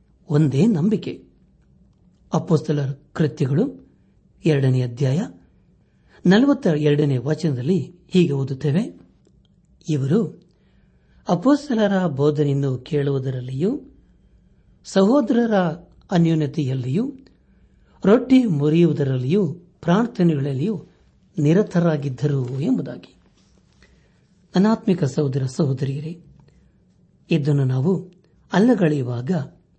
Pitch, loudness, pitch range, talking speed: 160 Hz, -20 LUFS, 145-190 Hz, 55 wpm